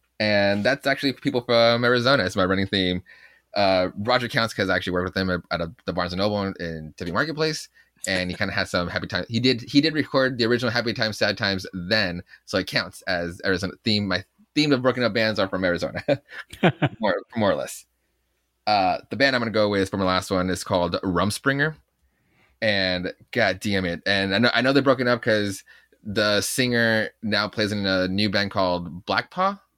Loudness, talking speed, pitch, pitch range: -23 LUFS, 220 wpm, 105 Hz, 95-120 Hz